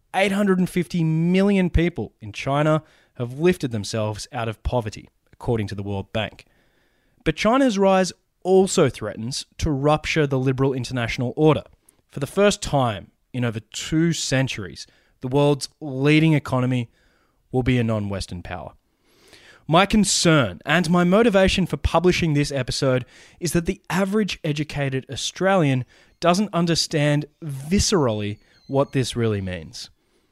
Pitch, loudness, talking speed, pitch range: 145 Hz, -21 LUFS, 135 wpm, 120-170 Hz